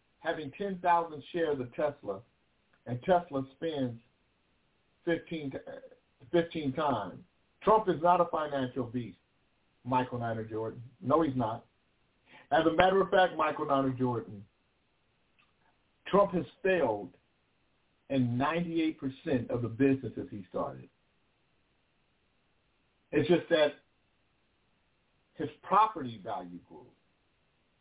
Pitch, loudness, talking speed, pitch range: 145 Hz, -31 LUFS, 105 wpm, 125-170 Hz